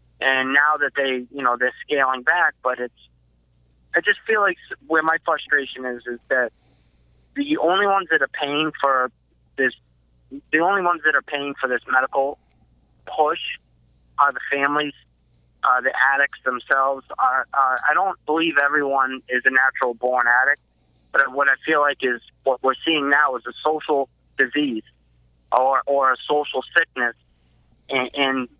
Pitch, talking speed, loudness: 130 Hz, 160 wpm, -20 LUFS